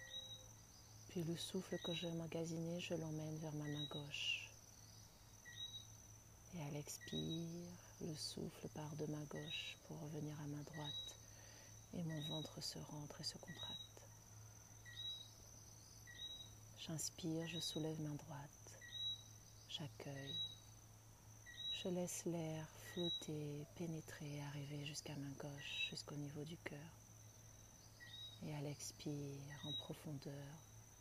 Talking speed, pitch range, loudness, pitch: 120 wpm, 110-150 Hz, -49 LUFS, 135 Hz